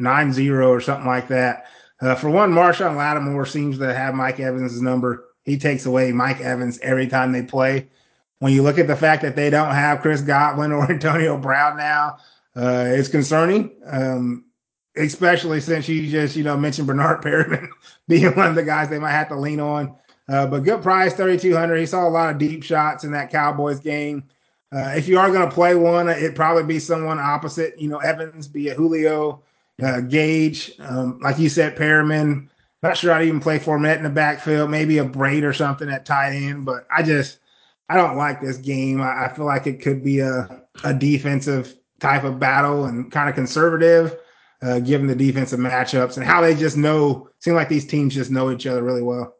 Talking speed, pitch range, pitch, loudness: 210 wpm, 130-155 Hz, 145 Hz, -19 LUFS